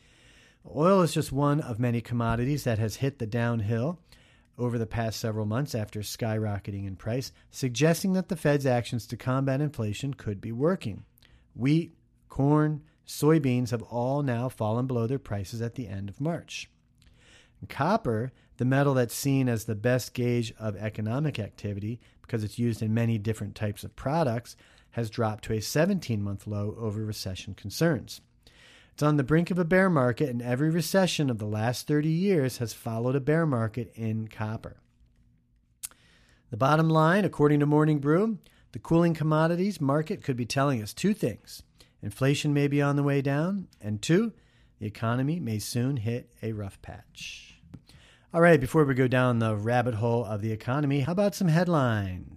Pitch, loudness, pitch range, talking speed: 125 Hz, -27 LUFS, 110-150 Hz, 175 wpm